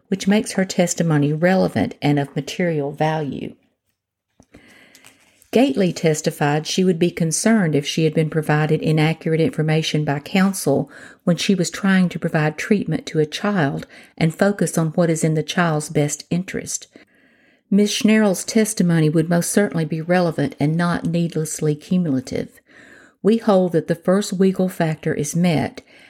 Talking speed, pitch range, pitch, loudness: 150 wpm, 155-190 Hz, 170 Hz, -19 LUFS